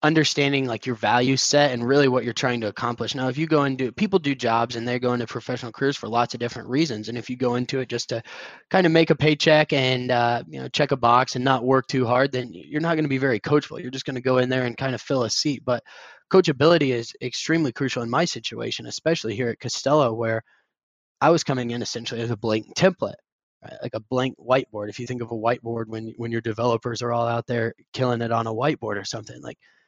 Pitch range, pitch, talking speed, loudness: 120-140 Hz, 125 Hz, 255 wpm, -23 LUFS